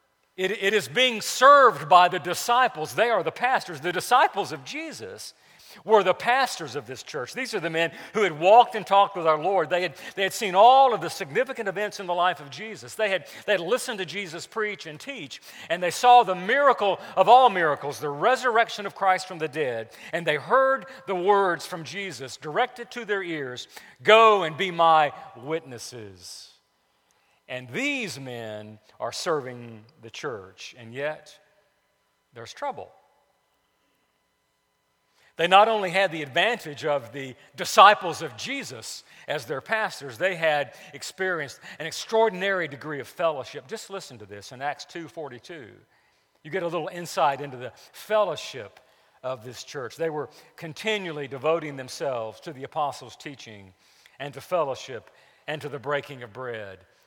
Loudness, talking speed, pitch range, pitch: -23 LUFS, 165 wpm, 145-210 Hz, 170 Hz